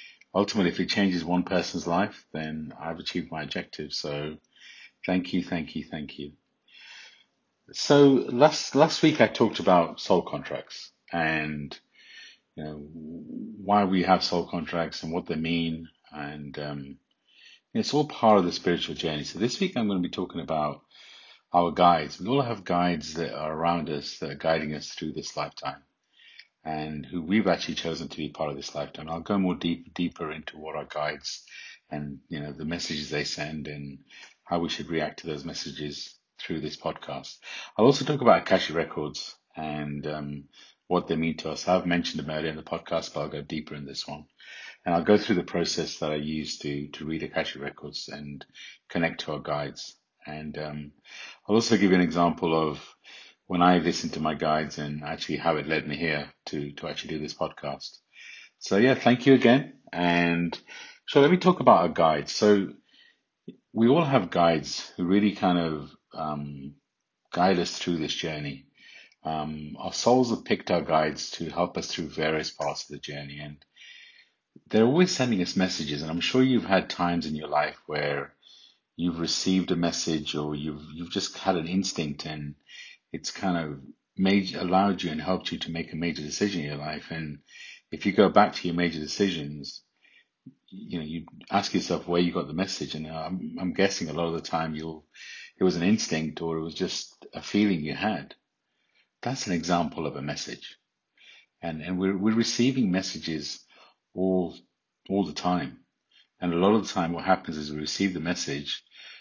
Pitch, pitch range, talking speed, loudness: 80 Hz, 75-90 Hz, 195 wpm, -27 LUFS